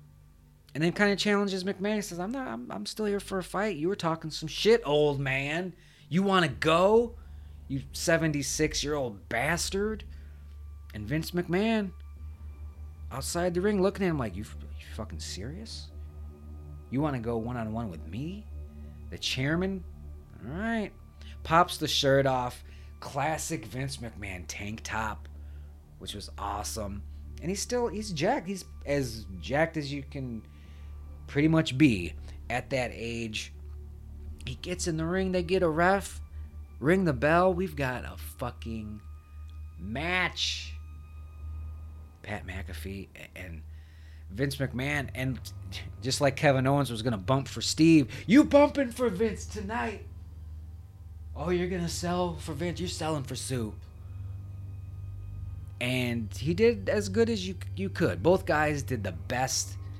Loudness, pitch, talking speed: -29 LUFS, 110 Hz, 150 wpm